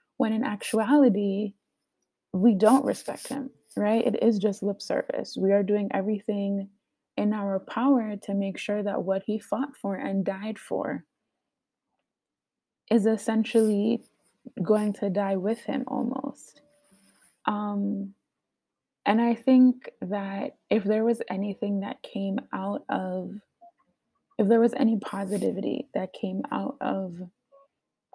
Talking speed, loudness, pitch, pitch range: 130 wpm, -27 LUFS, 215 Hz, 200-235 Hz